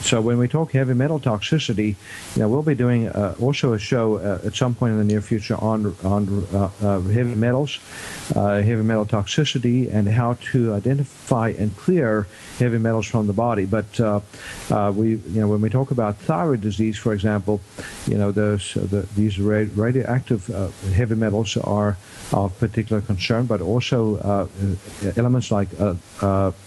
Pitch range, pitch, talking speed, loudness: 100-120 Hz, 110 Hz, 180 wpm, -21 LUFS